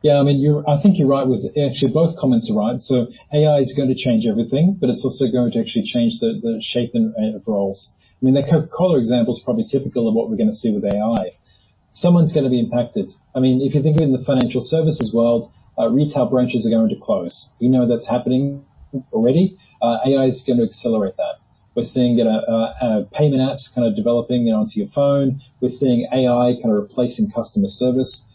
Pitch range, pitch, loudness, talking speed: 115-150 Hz, 130 Hz, -18 LUFS, 235 wpm